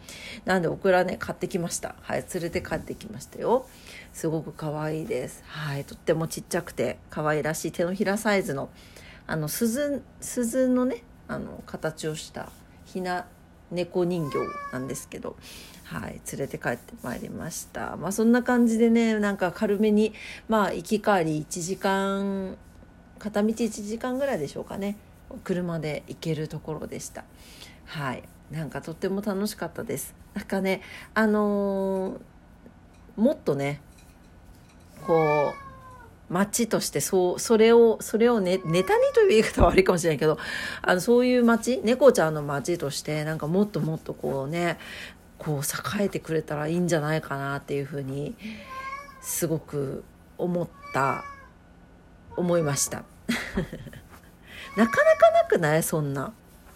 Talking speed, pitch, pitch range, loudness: 285 characters per minute, 180 Hz, 150-215 Hz, -26 LUFS